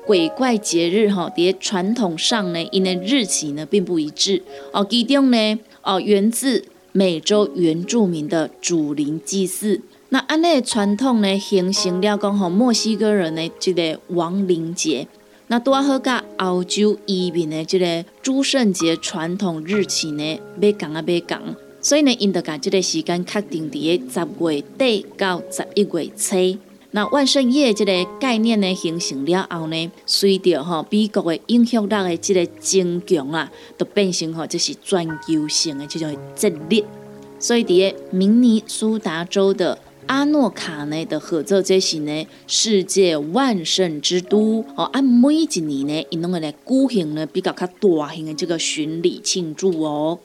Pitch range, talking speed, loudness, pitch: 165-210 Hz, 240 characters per minute, -19 LUFS, 185 Hz